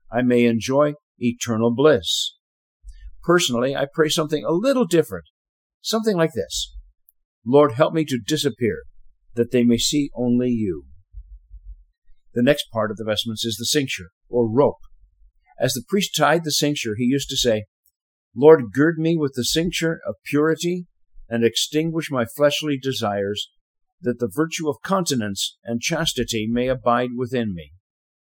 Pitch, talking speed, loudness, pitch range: 125 Hz, 150 wpm, -21 LUFS, 105-150 Hz